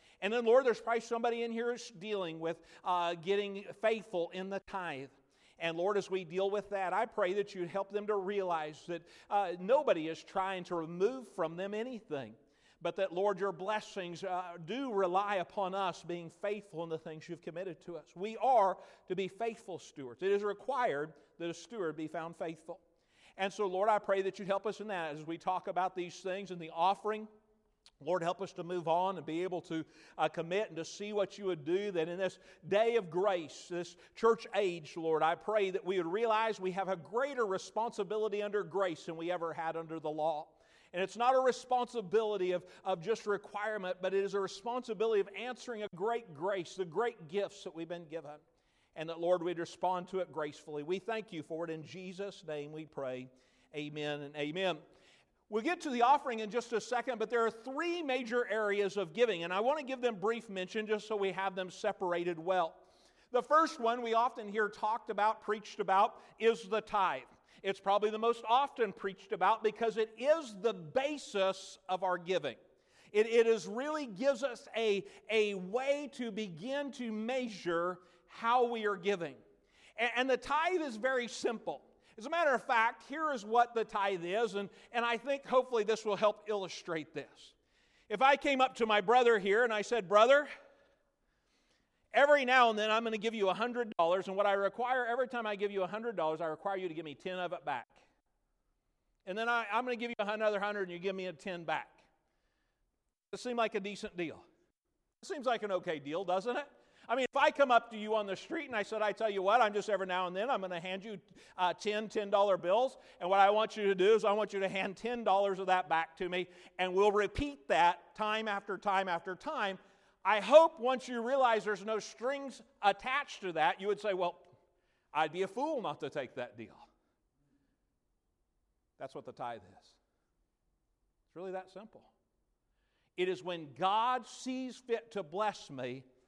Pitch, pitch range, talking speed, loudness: 200 Hz, 180-230 Hz, 210 wpm, -34 LUFS